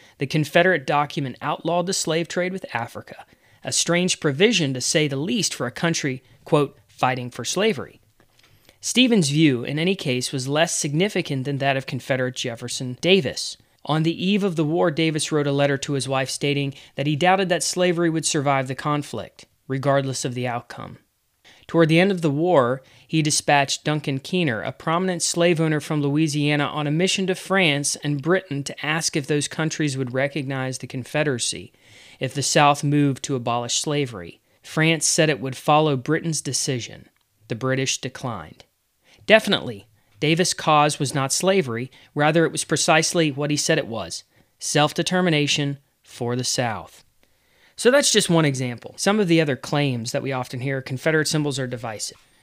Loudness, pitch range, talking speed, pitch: -21 LUFS, 130-165 Hz, 175 wpm, 145 Hz